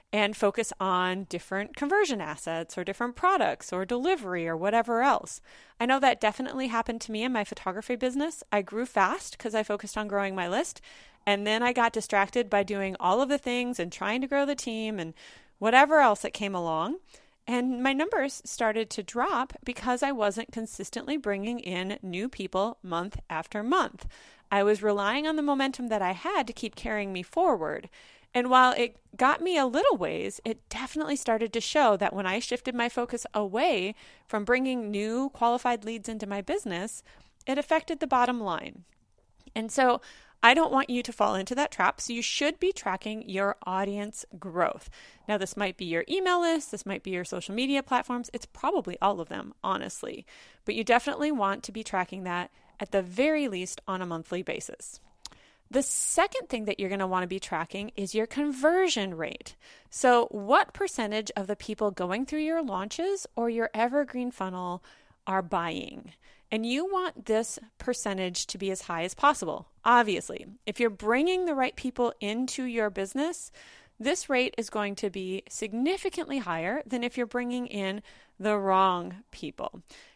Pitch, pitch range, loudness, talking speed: 230 Hz, 200-265 Hz, -28 LUFS, 185 wpm